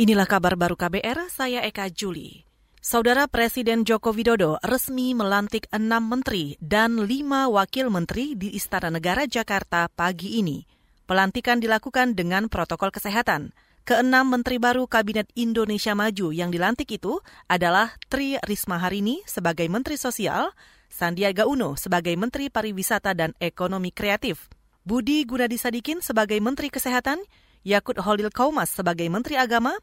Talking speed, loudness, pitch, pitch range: 130 wpm, -24 LUFS, 220 Hz, 190-250 Hz